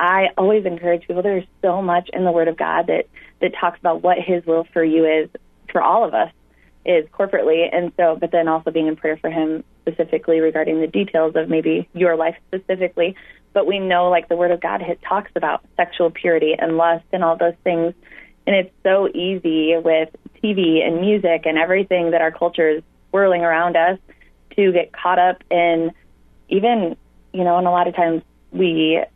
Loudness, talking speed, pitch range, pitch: -18 LUFS, 200 wpm, 165-180 Hz, 170 Hz